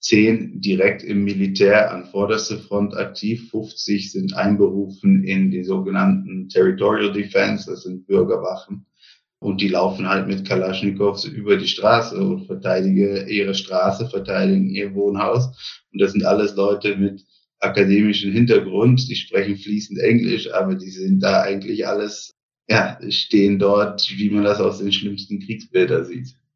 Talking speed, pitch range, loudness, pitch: 145 wpm, 100-125 Hz, -19 LUFS, 105 Hz